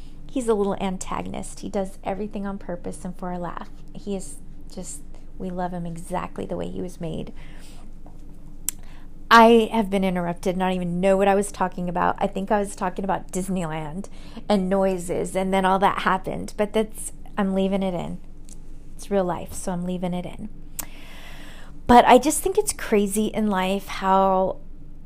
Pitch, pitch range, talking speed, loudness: 190 Hz, 175-200 Hz, 175 wpm, -23 LUFS